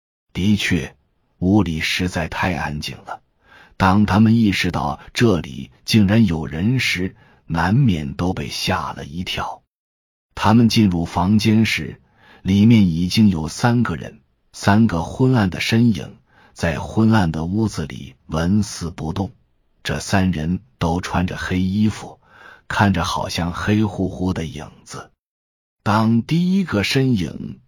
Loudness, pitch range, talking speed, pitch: -19 LUFS, 80-110 Hz, 195 characters per minute, 95 Hz